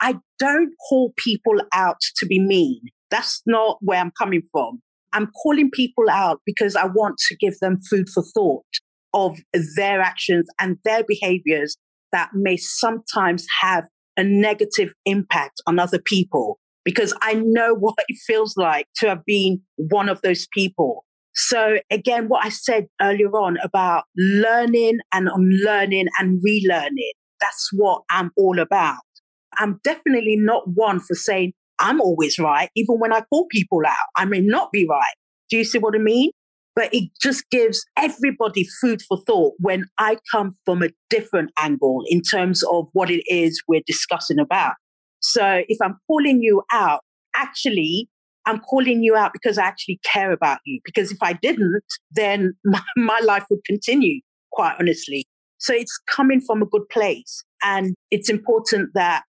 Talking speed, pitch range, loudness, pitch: 165 wpm, 185-235 Hz, -20 LUFS, 210 Hz